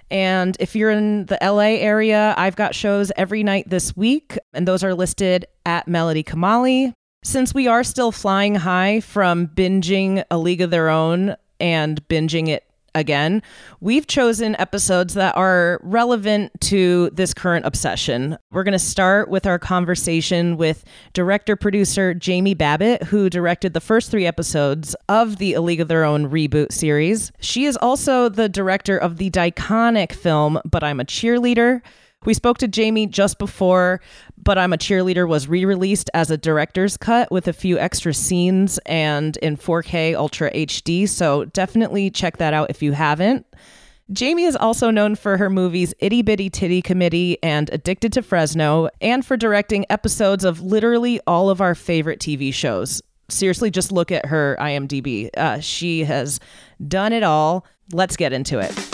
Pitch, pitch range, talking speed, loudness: 185 Hz, 165-210 Hz, 170 wpm, -18 LUFS